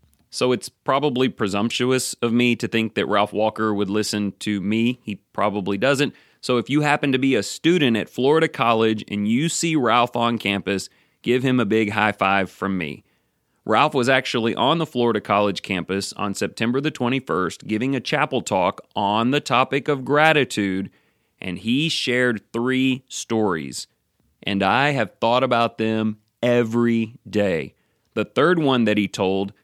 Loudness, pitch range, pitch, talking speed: -21 LUFS, 105-130 Hz, 115 Hz, 170 wpm